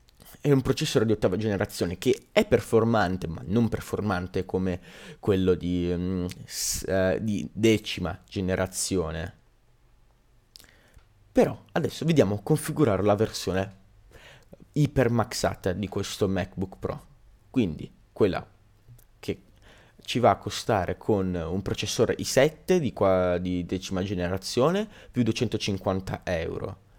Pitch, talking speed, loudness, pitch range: 100 Hz, 110 wpm, -27 LUFS, 95-115 Hz